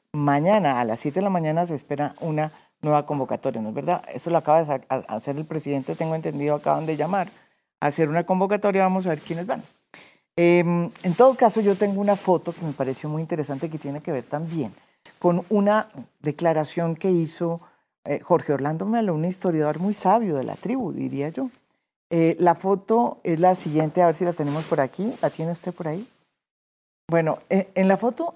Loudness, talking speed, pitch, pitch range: -23 LUFS, 200 wpm, 165 Hz, 150-185 Hz